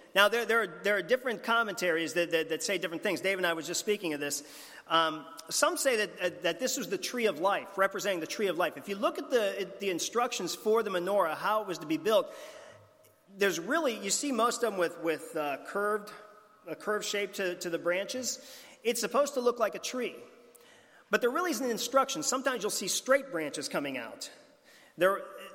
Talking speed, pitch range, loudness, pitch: 225 wpm, 180-245 Hz, -31 LUFS, 205 Hz